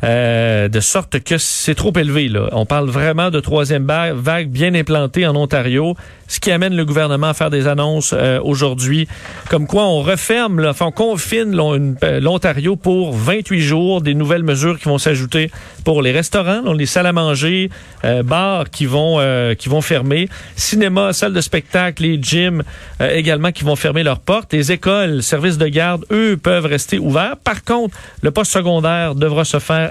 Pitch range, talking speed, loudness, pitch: 145-180 Hz, 195 wpm, -15 LUFS, 160 Hz